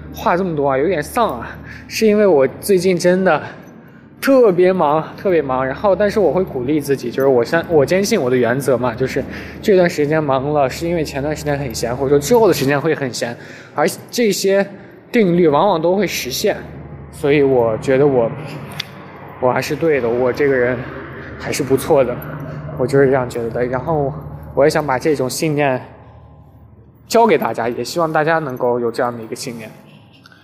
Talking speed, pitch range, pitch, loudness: 280 characters per minute, 125-170 Hz, 145 Hz, -16 LUFS